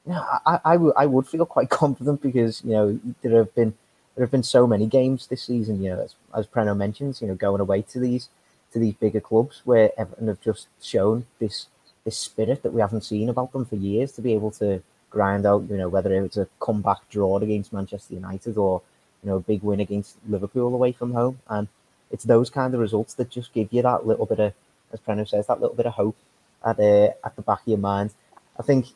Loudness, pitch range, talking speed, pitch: -23 LUFS, 100-125 Hz, 235 wpm, 110 Hz